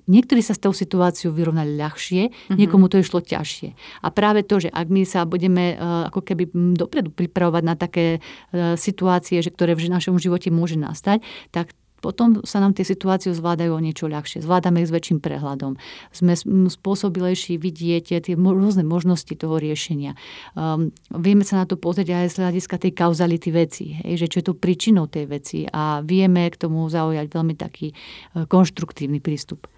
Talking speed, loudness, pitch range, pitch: 170 wpm, -21 LUFS, 165-185 Hz, 175 Hz